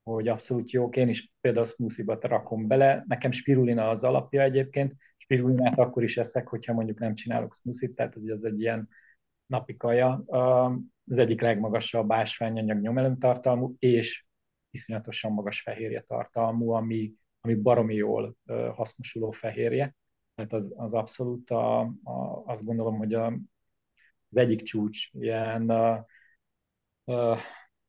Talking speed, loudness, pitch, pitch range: 135 wpm, -28 LUFS, 115 Hz, 110-125 Hz